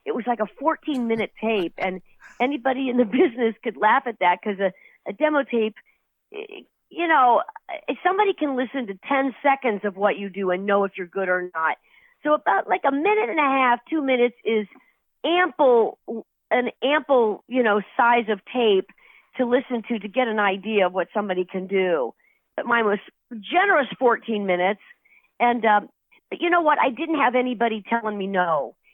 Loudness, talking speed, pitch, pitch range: -22 LUFS, 190 wpm, 240 Hz, 205-295 Hz